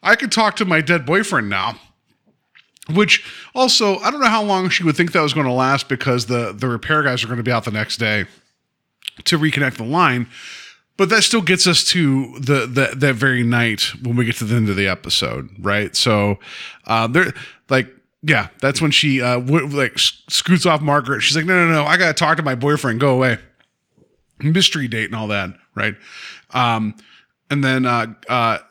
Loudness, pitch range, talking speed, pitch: -17 LUFS, 120-170 Hz, 210 wpm, 140 Hz